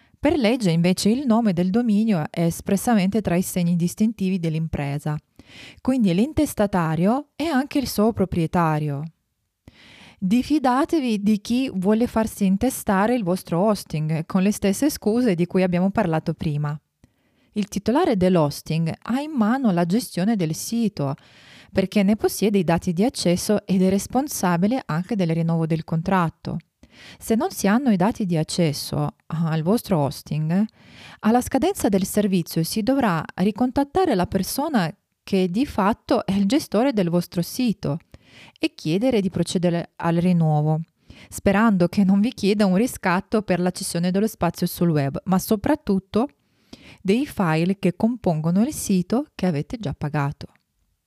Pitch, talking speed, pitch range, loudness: 195 Hz, 145 wpm, 175-225 Hz, -22 LUFS